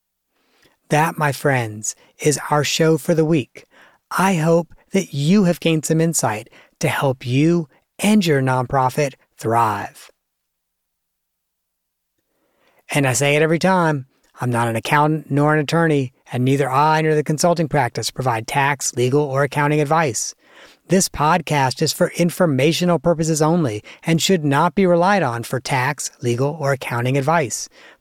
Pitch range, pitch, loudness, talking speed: 125-165 Hz, 145 Hz, -18 LUFS, 150 wpm